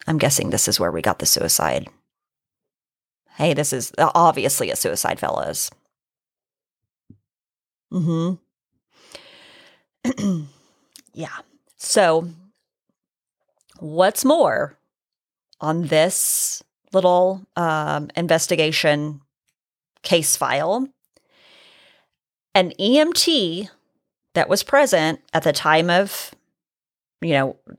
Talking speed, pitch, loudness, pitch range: 85 wpm, 180 Hz, -19 LUFS, 160-255 Hz